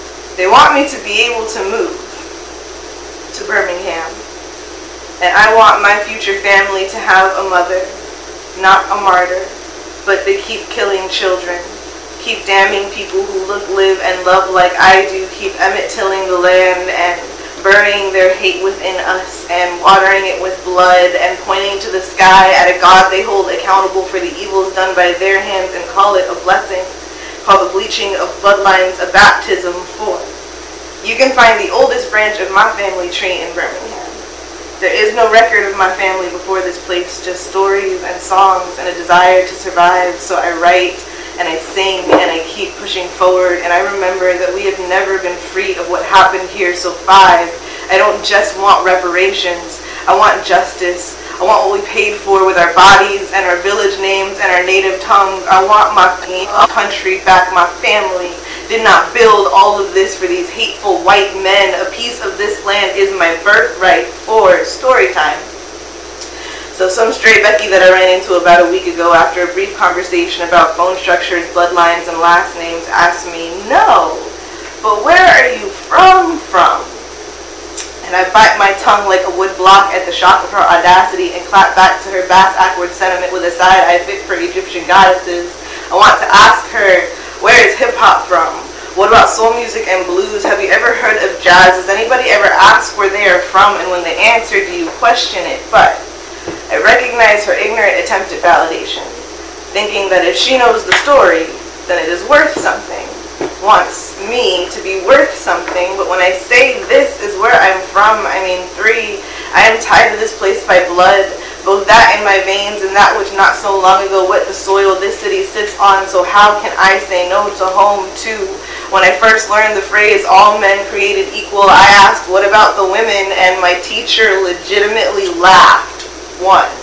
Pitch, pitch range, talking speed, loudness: 195 Hz, 185-220 Hz, 185 wpm, -9 LUFS